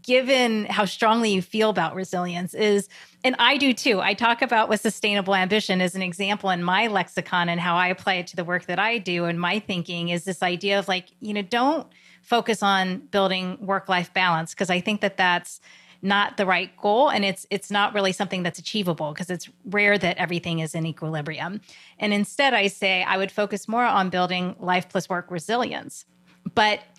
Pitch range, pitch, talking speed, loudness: 180-210 Hz, 195 Hz, 205 wpm, -23 LUFS